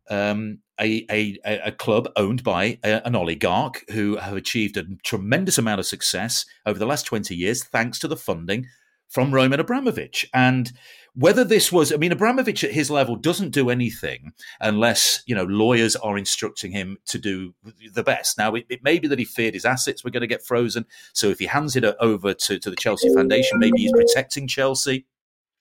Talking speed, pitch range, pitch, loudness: 195 wpm, 105-140 Hz, 120 Hz, -21 LUFS